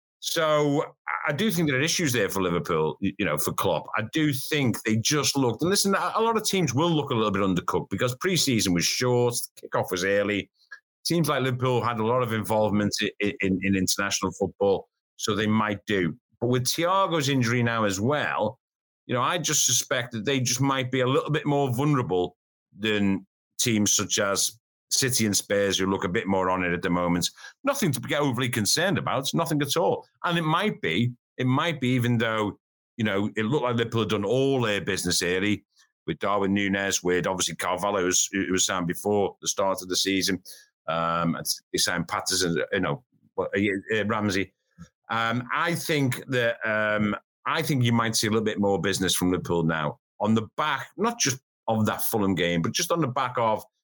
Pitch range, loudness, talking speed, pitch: 100-140 Hz, -25 LUFS, 205 wpm, 110 Hz